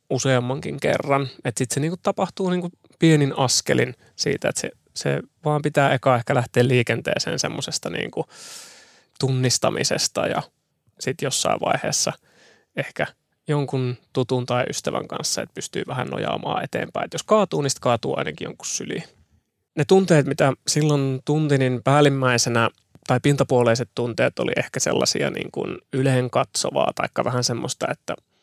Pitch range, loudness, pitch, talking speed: 125-145 Hz, -22 LUFS, 130 Hz, 135 wpm